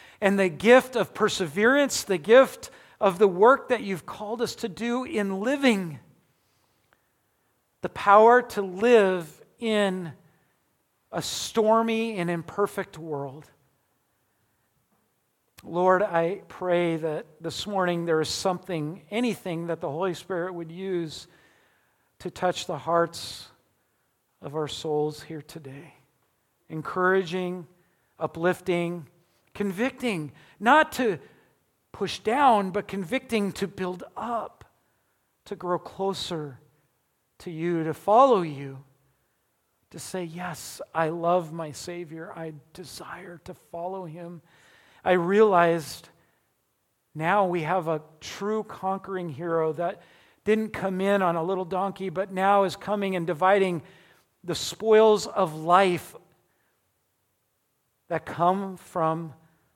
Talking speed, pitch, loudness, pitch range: 115 wpm, 180 Hz, -25 LUFS, 160-195 Hz